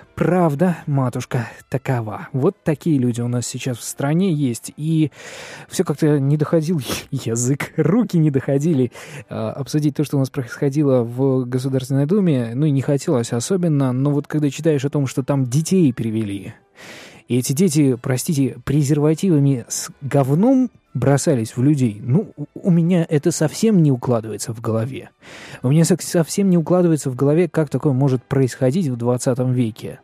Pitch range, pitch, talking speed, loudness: 130-160 Hz, 140 Hz, 160 wpm, -19 LUFS